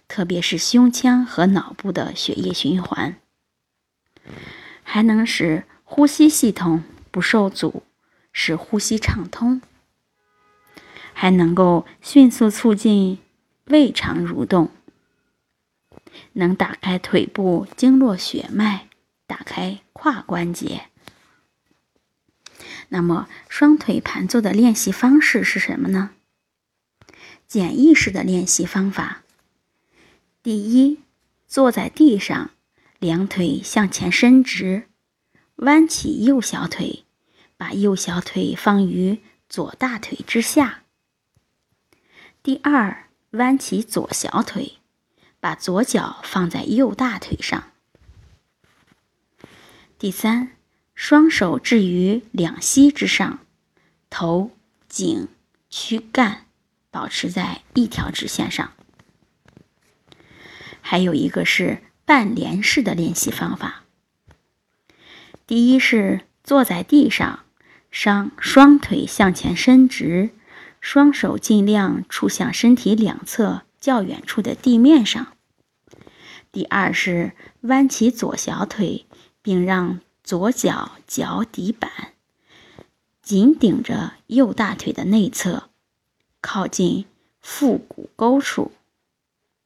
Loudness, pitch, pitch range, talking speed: -18 LUFS, 220 Hz, 190-260 Hz, 145 characters per minute